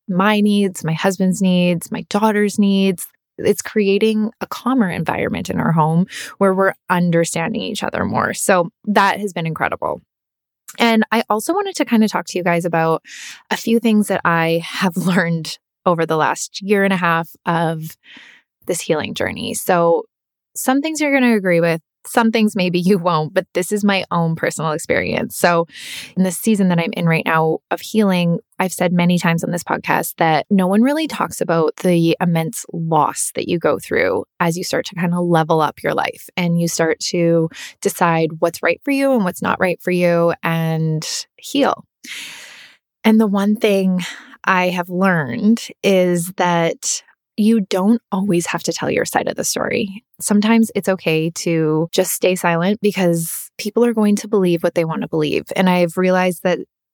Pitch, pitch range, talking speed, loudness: 185 Hz, 170-210 Hz, 185 wpm, -17 LUFS